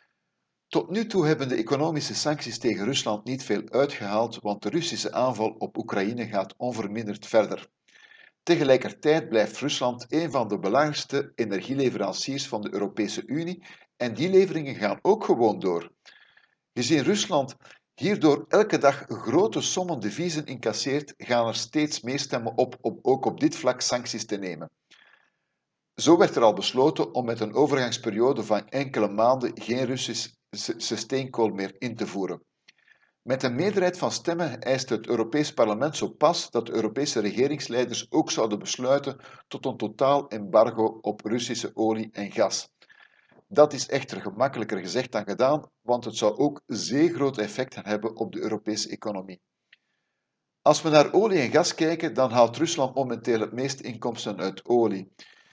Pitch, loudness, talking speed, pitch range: 130 Hz, -26 LUFS, 155 wpm, 110-150 Hz